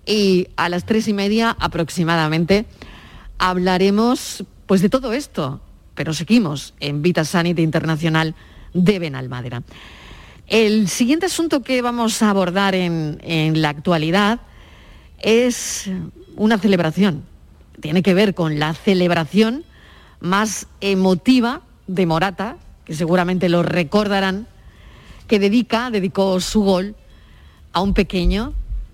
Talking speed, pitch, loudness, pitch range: 115 wpm, 190 Hz, -18 LUFS, 165-210 Hz